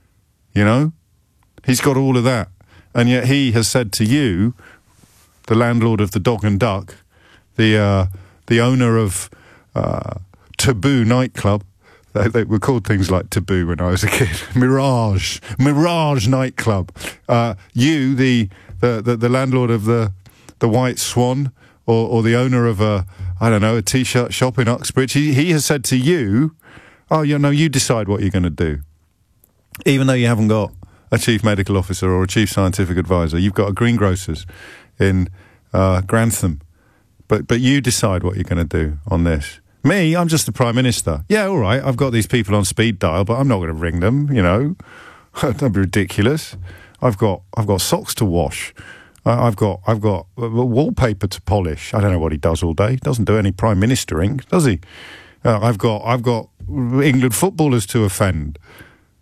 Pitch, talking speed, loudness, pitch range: 110 Hz, 190 wpm, -17 LUFS, 95-125 Hz